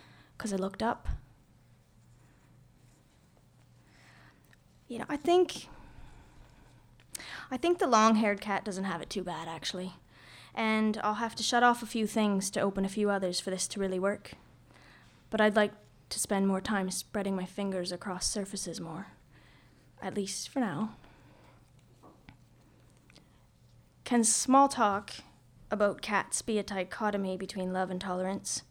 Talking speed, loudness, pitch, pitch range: 140 wpm, -31 LUFS, 195 Hz, 180-215 Hz